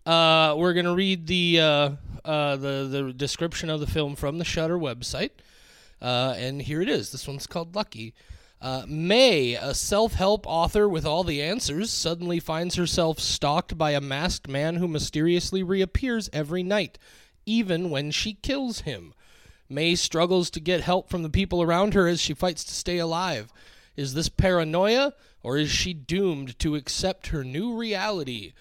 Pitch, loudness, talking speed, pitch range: 165 Hz, -25 LUFS, 170 wpm, 145-185 Hz